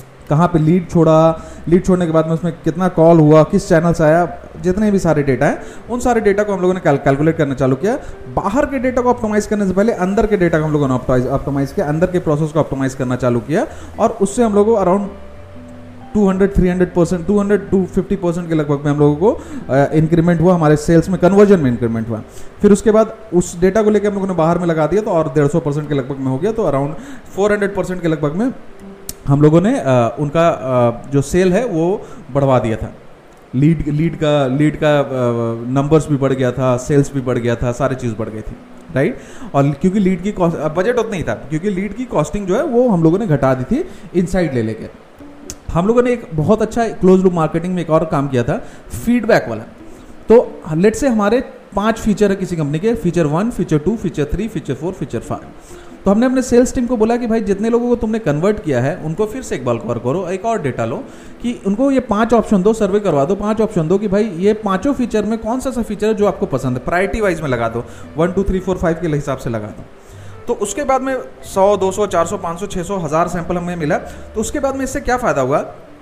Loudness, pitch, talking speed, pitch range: -16 LUFS, 175 Hz, 240 wpm, 145-210 Hz